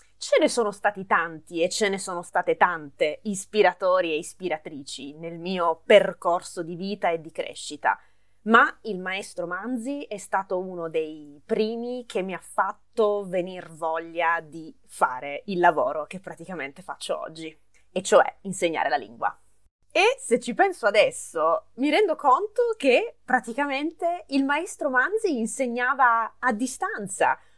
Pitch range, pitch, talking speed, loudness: 170-255 Hz, 195 Hz, 145 wpm, -25 LUFS